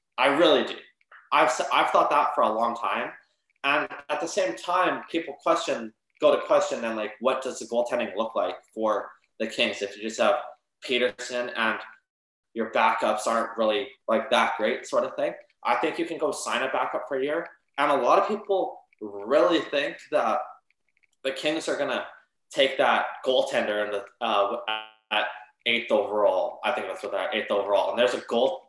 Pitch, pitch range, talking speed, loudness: 115 Hz, 105-125 Hz, 190 wpm, -26 LUFS